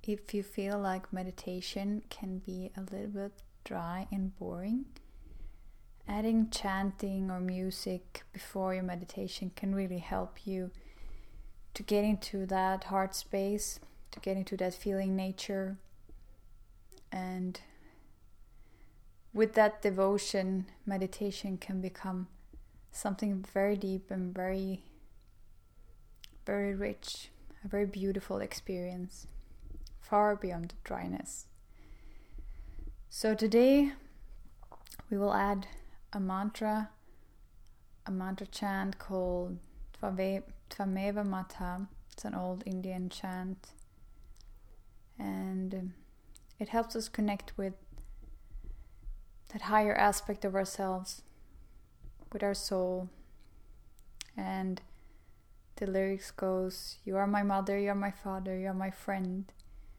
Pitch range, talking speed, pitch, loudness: 135-200 Hz, 105 wpm, 190 Hz, -35 LUFS